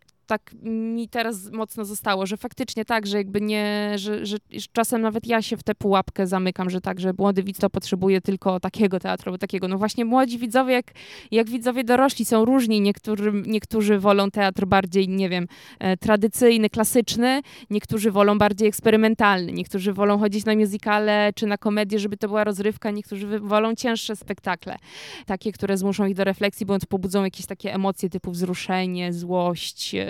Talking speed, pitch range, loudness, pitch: 170 wpm, 195-220 Hz, -23 LUFS, 210 Hz